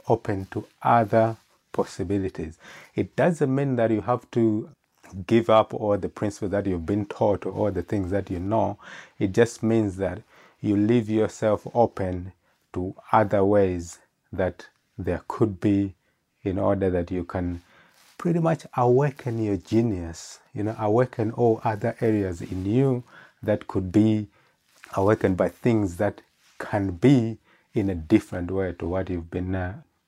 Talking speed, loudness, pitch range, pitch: 155 wpm, -25 LUFS, 95-115 Hz, 105 Hz